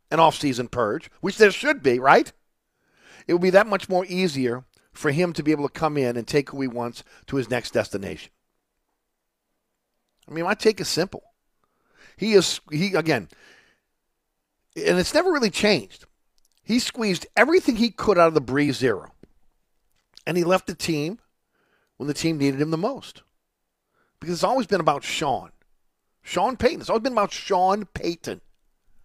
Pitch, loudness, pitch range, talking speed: 175 Hz, -22 LUFS, 145-210 Hz, 175 wpm